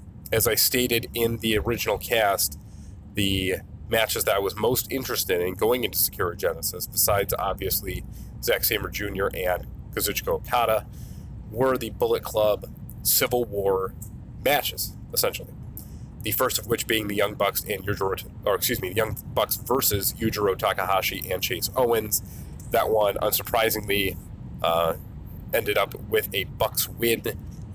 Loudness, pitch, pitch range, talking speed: -24 LUFS, 110 Hz, 100-125 Hz, 145 wpm